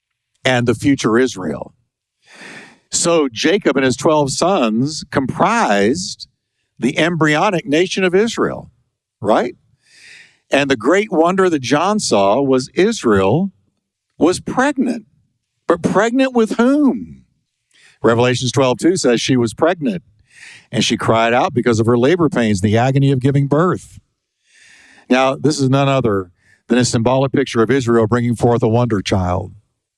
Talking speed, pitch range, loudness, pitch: 140 wpm, 120-165 Hz, -15 LUFS, 135 Hz